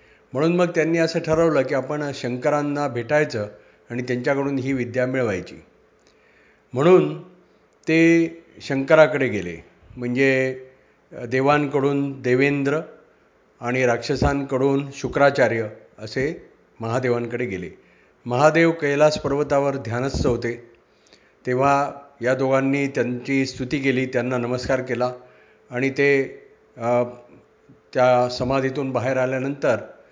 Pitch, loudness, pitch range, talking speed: 135 Hz, -21 LUFS, 125-145 Hz, 95 wpm